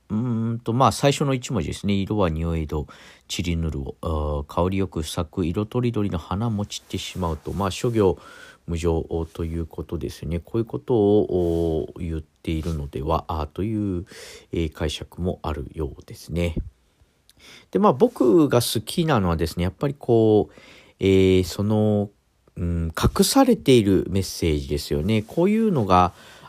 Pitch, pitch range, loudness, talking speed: 95 Hz, 85-115 Hz, -23 LUFS, 305 characters per minute